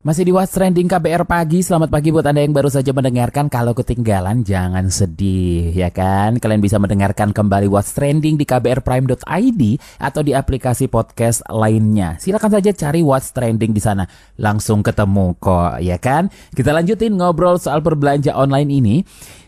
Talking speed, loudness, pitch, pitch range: 160 wpm, -16 LUFS, 125 Hz, 105-155 Hz